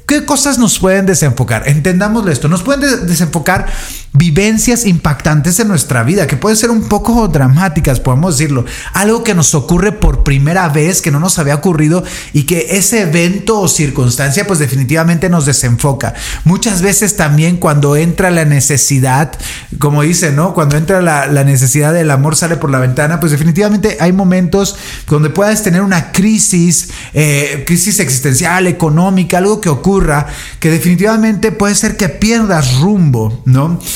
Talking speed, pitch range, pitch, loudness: 160 wpm, 145-195 Hz, 170 Hz, -10 LUFS